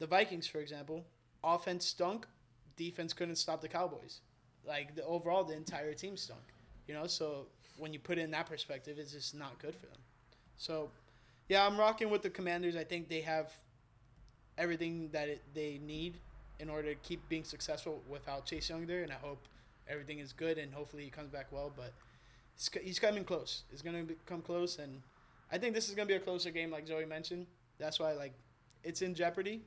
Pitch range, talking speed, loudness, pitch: 140-170 Hz, 205 wpm, -40 LUFS, 155 Hz